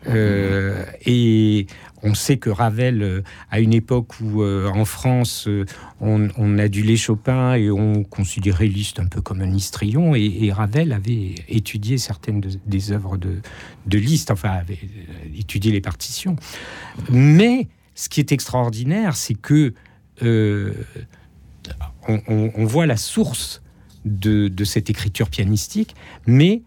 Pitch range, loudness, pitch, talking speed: 100-120 Hz, -20 LUFS, 110 Hz, 140 wpm